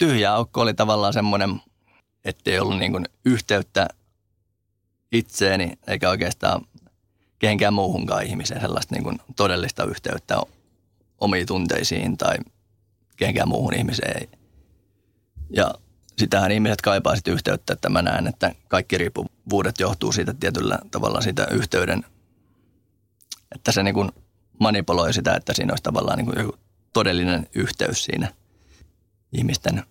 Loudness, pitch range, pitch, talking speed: -23 LUFS, 95-105 Hz, 100 Hz, 115 wpm